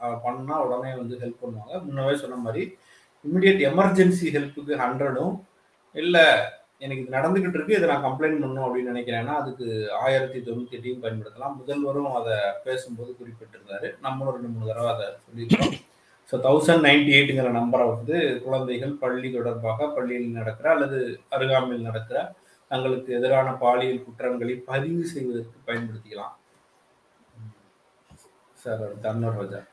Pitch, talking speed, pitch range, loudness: 130 Hz, 125 wpm, 120-140 Hz, -24 LUFS